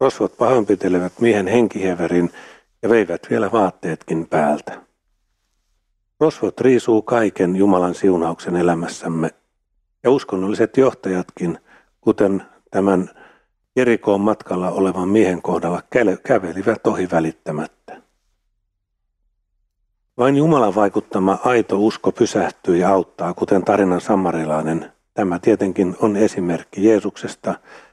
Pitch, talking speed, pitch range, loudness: 95 Hz, 95 wpm, 90-110 Hz, -18 LUFS